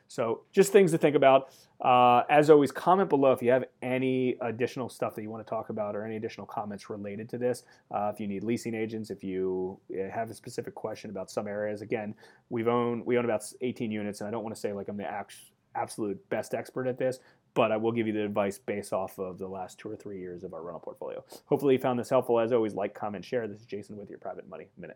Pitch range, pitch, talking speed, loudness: 105-130 Hz, 115 Hz, 255 wpm, -29 LUFS